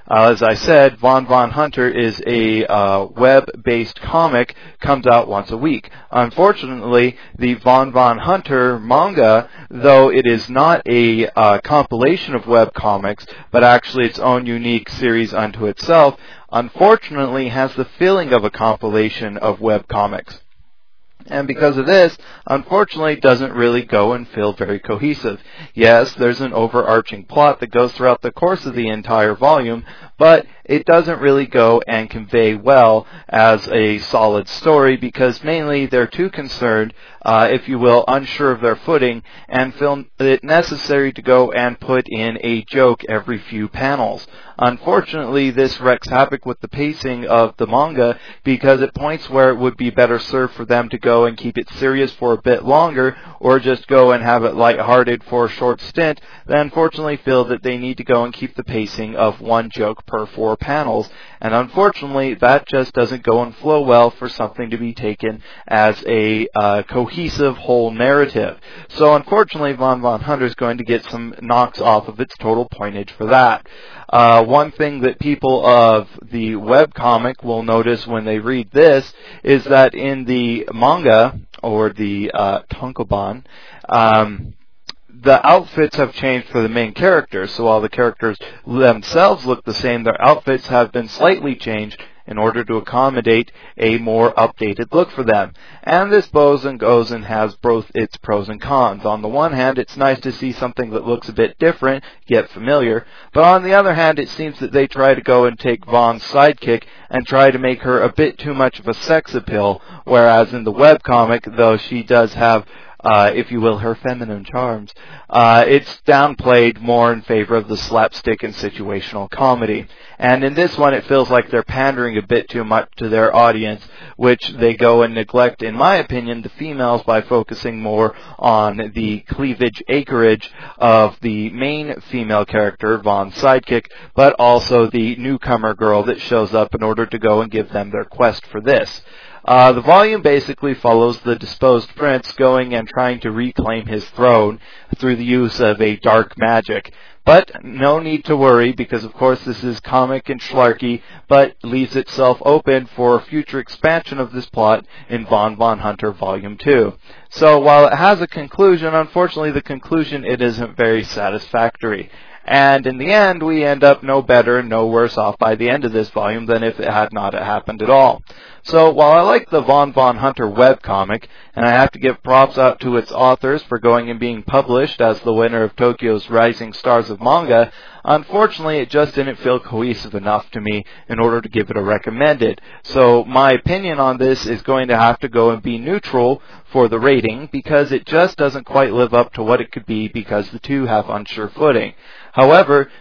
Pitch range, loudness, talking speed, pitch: 115-135 Hz, -15 LUFS, 185 wpm, 120 Hz